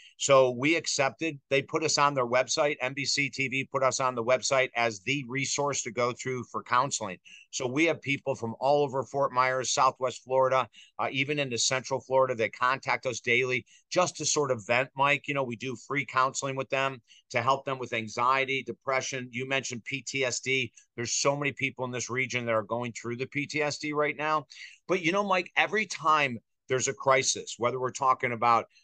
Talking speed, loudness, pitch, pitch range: 200 wpm, -28 LUFS, 130 Hz, 125-140 Hz